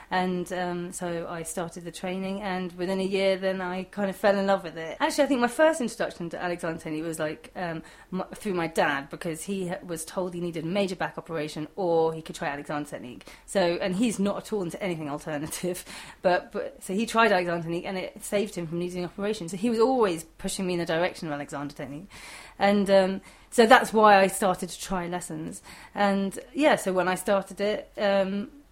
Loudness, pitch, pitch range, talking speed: -27 LUFS, 185 Hz, 170-200 Hz, 220 wpm